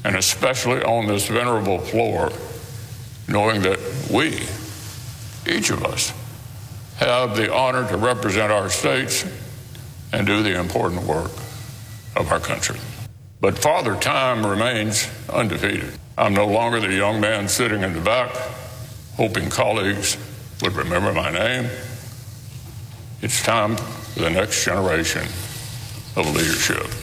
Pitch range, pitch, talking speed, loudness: 105-120 Hz, 110 Hz, 125 wpm, -21 LUFS